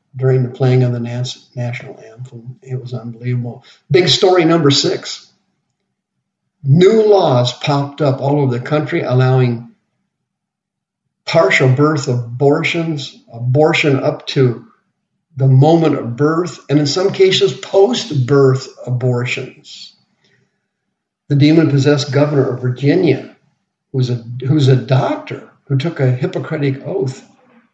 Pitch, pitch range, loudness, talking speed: 140 Hz, 125-160 Hz, -14 LUFS, 115 wpm